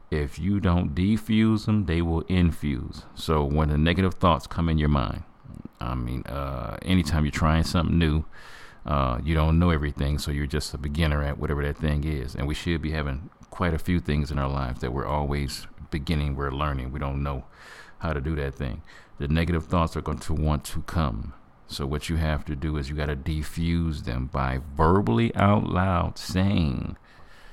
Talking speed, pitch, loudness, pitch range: 200 wpm, 75 Hz, -26 LUFS, 70-85 Hz